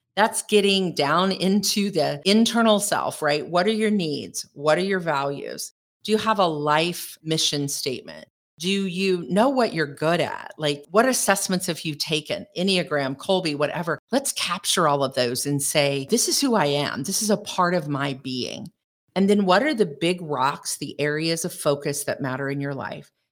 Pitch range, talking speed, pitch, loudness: 145-195 Hz, 190 wpm, 175 Hz, -23 LUFS